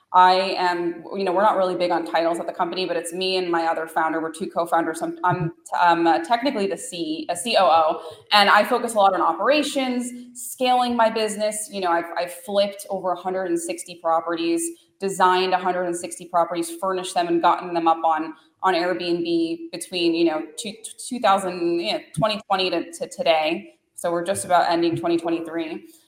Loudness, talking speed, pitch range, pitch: -22 LUFS, 175 wpm, 170-205 Hz, 180 Hz